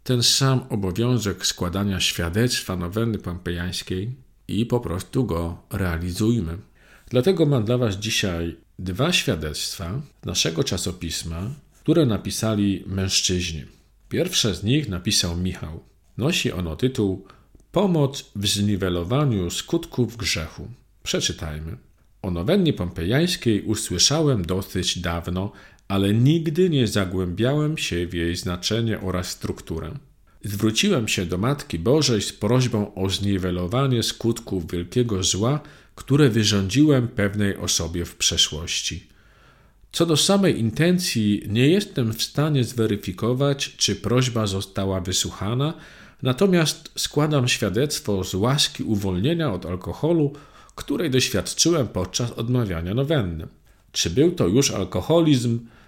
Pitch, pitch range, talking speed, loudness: 110 Hz, 95-130 Hz, 110 wpm, -22 LUFS